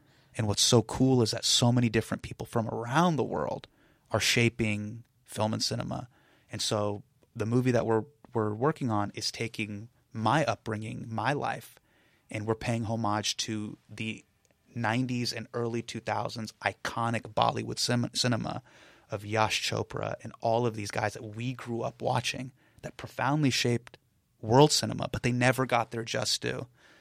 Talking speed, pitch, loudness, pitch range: 160 wpm, 115 Hz, -29 LUFS, 110-125 Hz